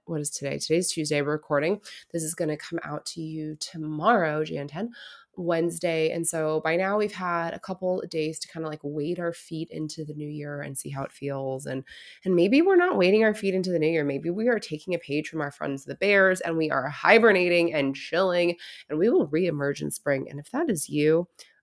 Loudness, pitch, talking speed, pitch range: -26 LUFS, 160 Hz, 235 wpm, 150-180 Hz